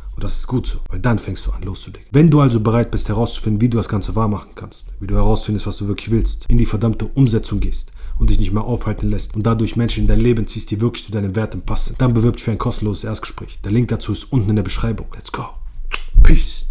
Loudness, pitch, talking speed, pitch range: -19 LUFS, 110 Hz, 260 wpm, 105-115 Hz